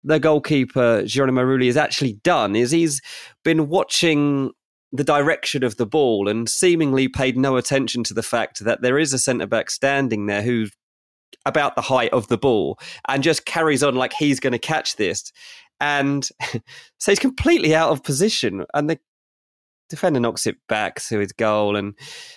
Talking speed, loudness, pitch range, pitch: 175 wpm, -20 LUFS, 120-155 Hz, 135 Hz